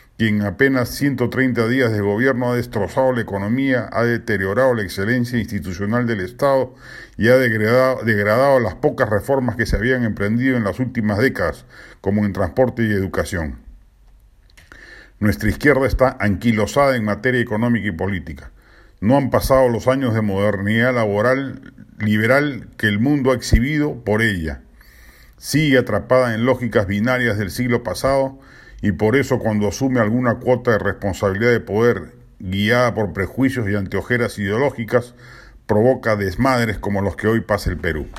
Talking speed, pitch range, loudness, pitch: 150 wpm, 105-130 Hz, -18 LUFS, 115 Hz